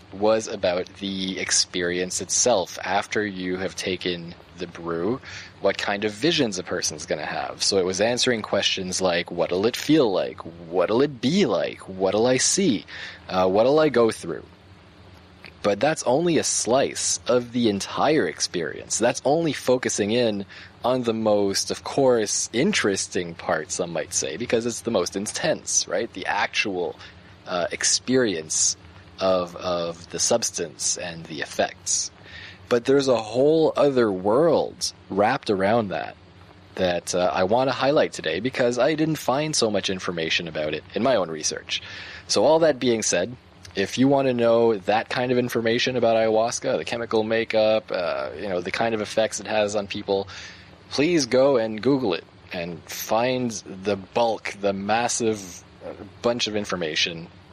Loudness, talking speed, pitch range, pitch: -23 LUFS, 160 wpm, 95-115 Hz, 100 Hz